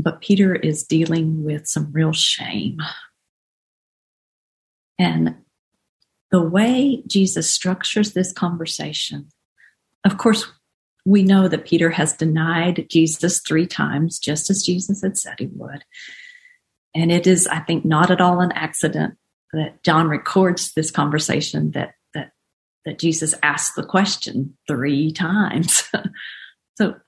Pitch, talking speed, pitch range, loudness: 165 Hz, 130 wpm, 155-190 Hz, -19 LUFS